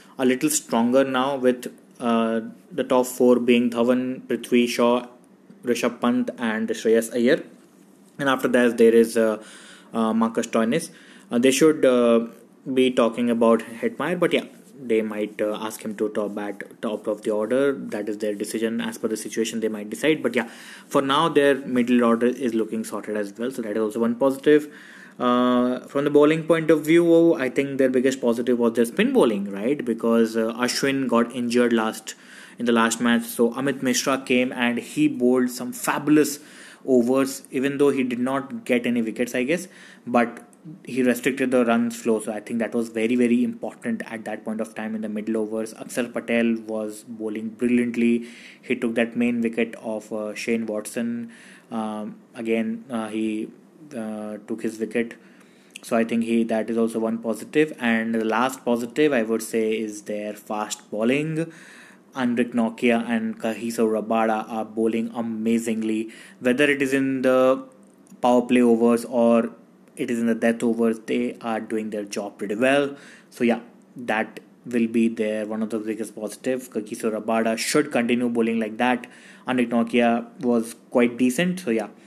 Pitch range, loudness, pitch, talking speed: 110-125 Hz, -23 LUFS, 120 Hz, 180 wpm